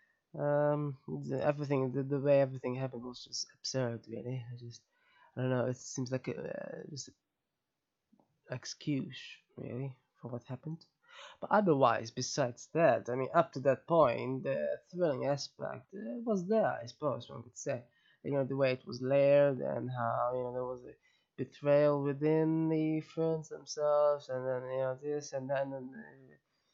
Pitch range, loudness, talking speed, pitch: 125-150 Hz, -34 LUFS, 170 wpm, 135 Hz